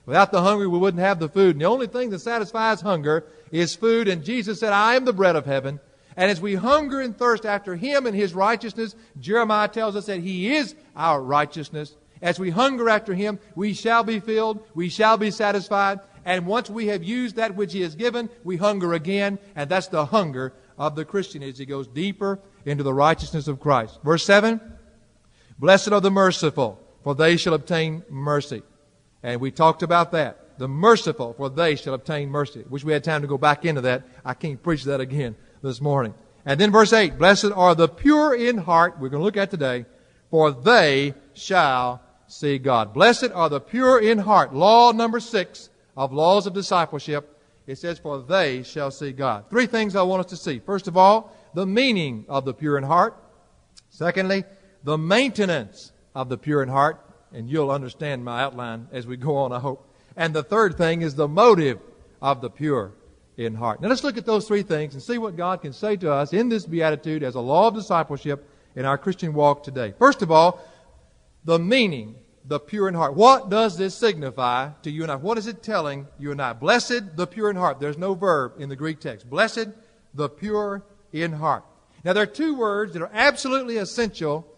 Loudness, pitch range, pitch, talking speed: -21 LUFS, 145-210 Hz, 170 Hz, 210 wpm